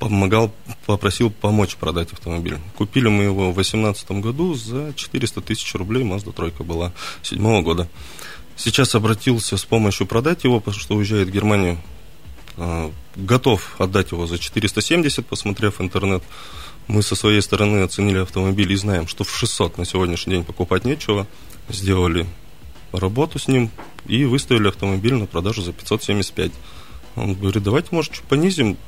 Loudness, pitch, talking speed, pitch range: -20 LUFS, 100 Hz, 150 wpm, 90-115 Hz